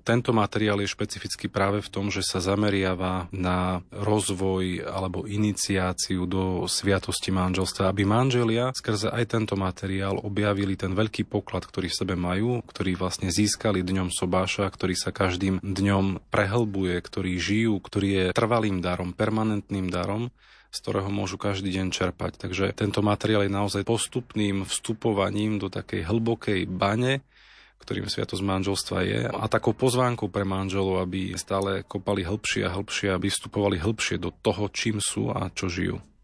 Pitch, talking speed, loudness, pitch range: 100 Hz, 150 wpm, -26 LUFS, 95-105 Hz